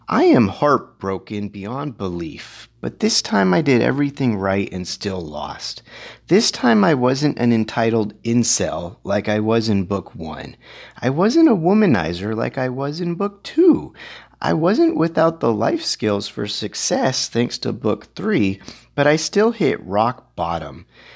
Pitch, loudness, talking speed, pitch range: 120 Hz, -19 LUFS, 160 wpm, 105-160 Hz